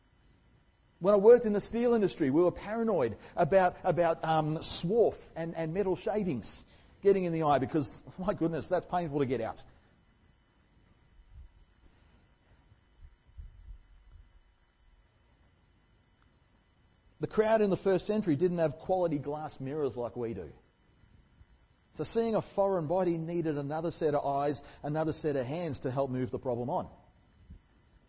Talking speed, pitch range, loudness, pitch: 140 wpm, 105-180 Hz, -31 LUFS, 150 Hz